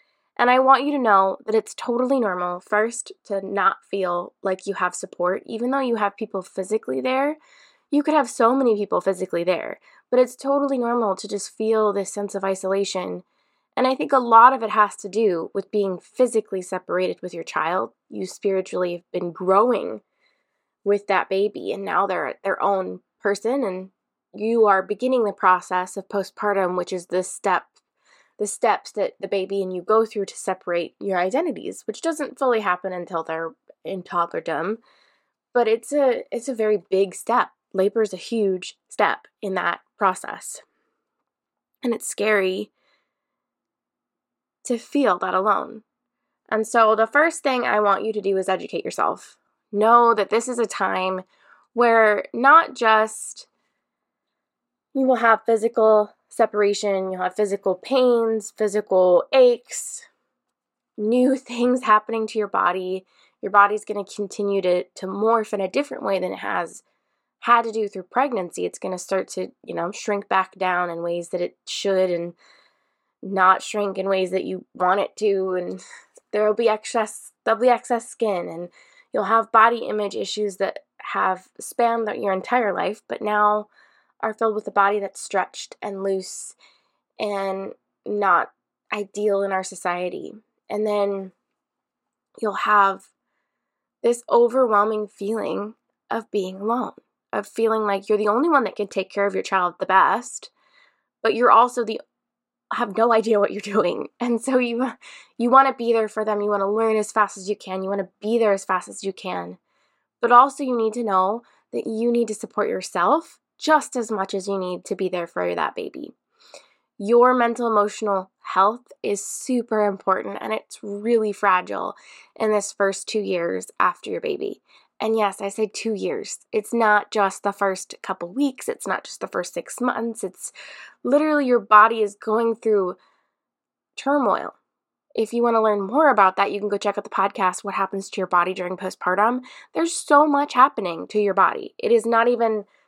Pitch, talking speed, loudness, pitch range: 210 Hz, 175 wpm, -22 LUFS, 190-235 Hz